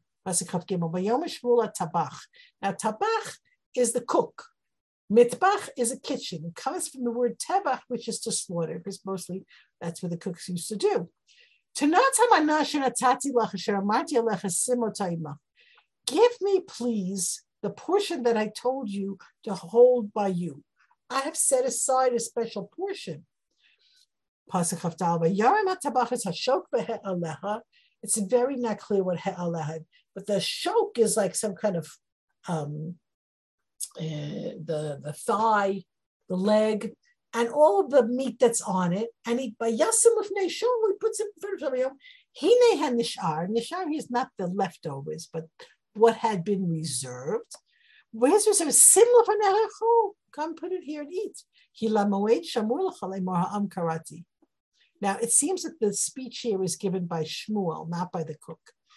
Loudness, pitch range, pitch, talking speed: -26 LUFS, 185-310 Hz, 230 Hz, 125 wpm